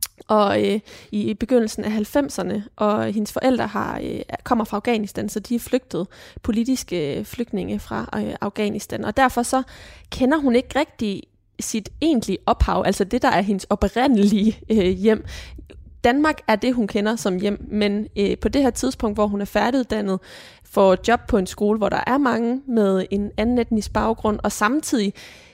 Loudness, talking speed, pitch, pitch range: -21 LUFS, 175 wpm, 215 Hz, 205-245 Hz